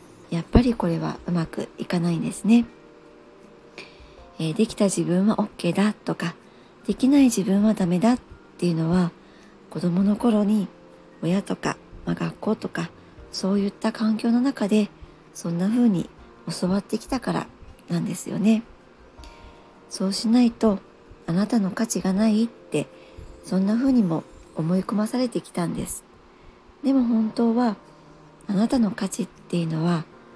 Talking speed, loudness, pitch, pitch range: 285 characters per minute, -24 LUFS, 200 Hz, 170-220 Hz